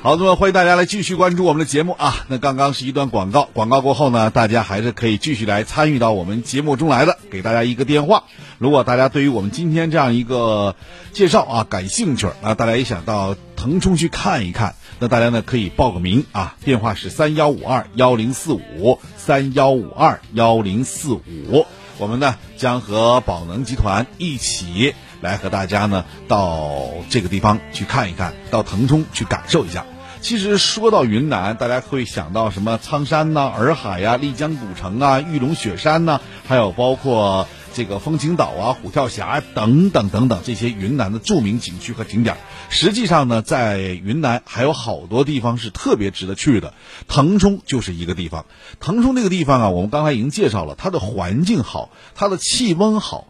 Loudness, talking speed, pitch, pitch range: -18 LUFS, 300 characters per minute, 120 Hz, 105-145 Hz